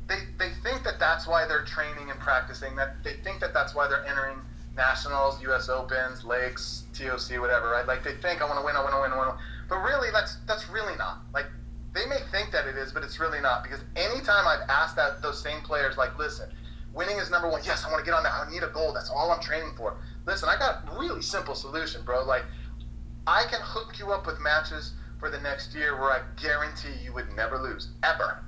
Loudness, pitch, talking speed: -28 LUFS, 130 Hz, 240 wpm